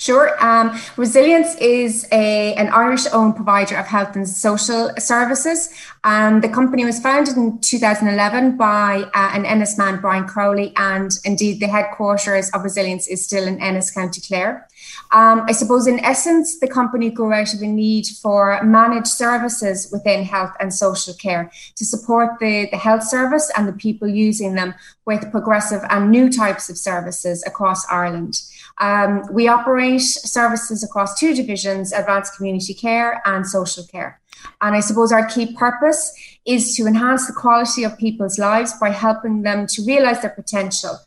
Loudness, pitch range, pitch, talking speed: -17 LUFS, 200-235 Hz, 215 Hz, 165 wpm